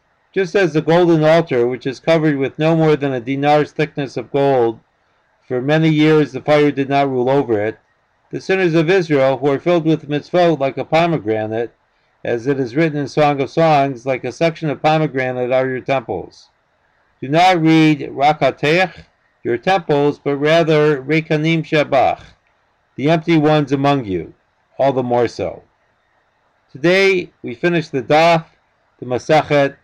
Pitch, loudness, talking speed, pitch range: 150 Hz, -16 LUFS, 165 wpm, 135-160 Hz